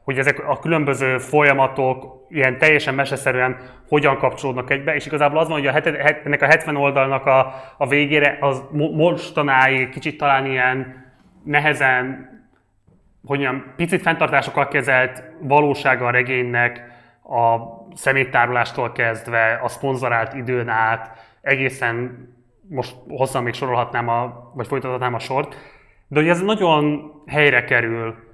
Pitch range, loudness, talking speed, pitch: 125-145 Hz, -18 LUFS, 135 wpm, 130 Hz